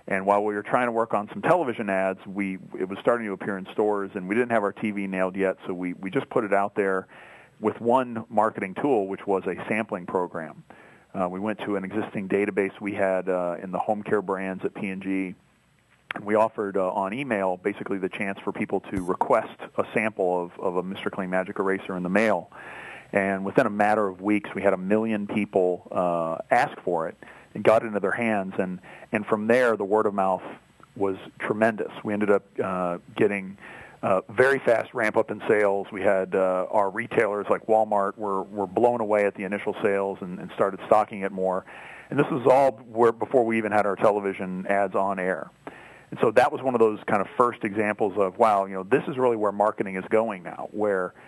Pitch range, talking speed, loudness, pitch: 95-110 Hz, 220 wpm, -25 LUFS, 100 Hz